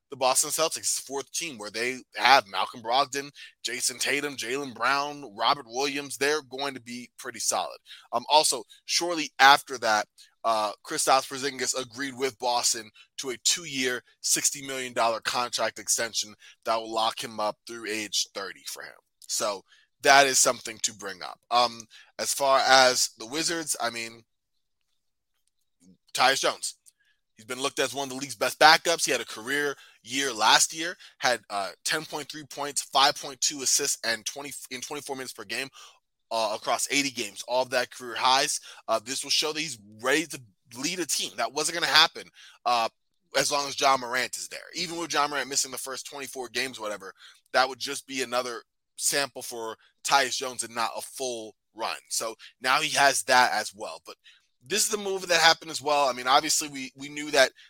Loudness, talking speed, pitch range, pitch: -26 LUFS, 185 wpm, 120-145 Hz, 130 Hz